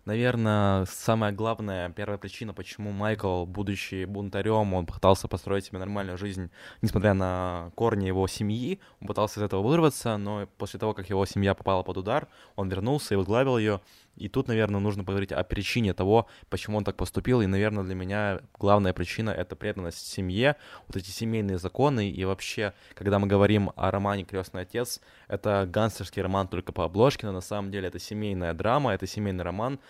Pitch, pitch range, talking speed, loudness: 100 Hz, 95-110 Hz, 180 wpm, -28 LUFS